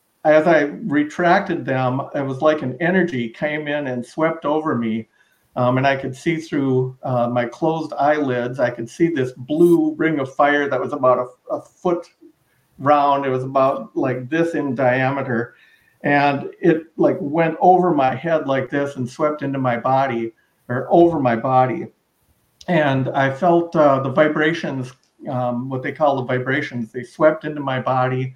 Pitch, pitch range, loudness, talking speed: 140 Hz, 130-155 Hz, -19 LUFS, 175 wpm